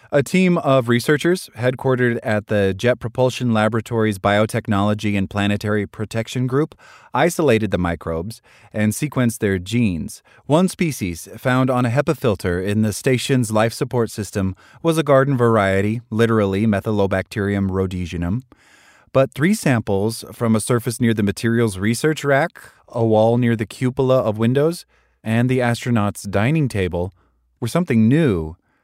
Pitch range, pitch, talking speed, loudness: 105-130 Hz, 115 Hz, 140 wpm, -19 LUFS